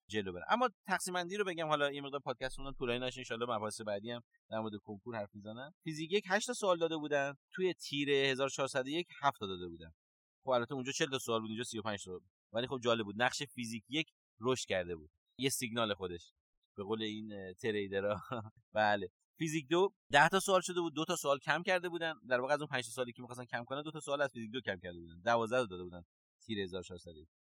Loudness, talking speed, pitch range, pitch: -36 LUFS, 230 wpm, 105-150 Hz, 125 Hz